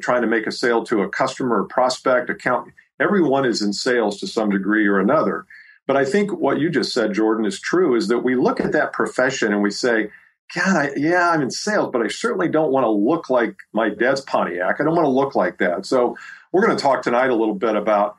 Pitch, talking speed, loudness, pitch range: 110 Hz, 245 wpm, -19 LUFS, 105-125 Hz